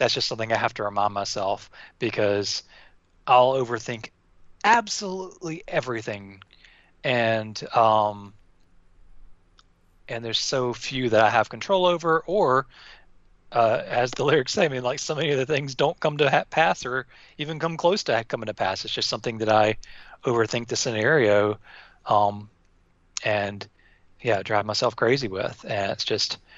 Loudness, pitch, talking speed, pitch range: -24 LUFS, 110 Hz, 155 wpm, 100-130 Hz